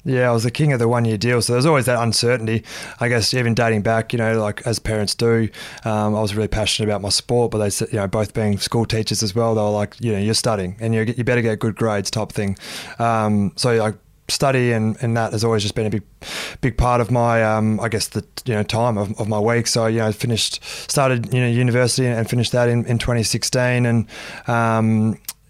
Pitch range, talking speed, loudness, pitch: 110-120 Hz, 250 wpm, -19 LUFS, 115 Hz